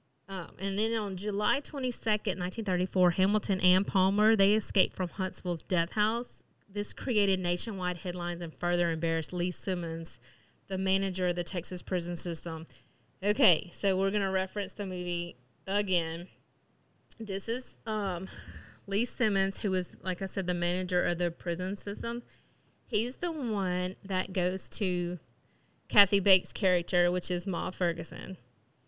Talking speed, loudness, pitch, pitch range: 145 wpm, -30 LUFS, 185 Hz, 175-200 Hz